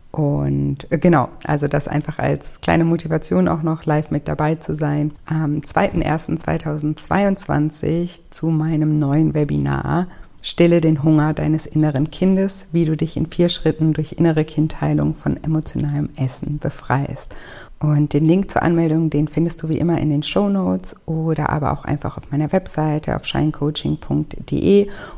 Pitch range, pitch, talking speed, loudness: 145-165 Hz, 155 Hz, 150 wpm, -19 LUFS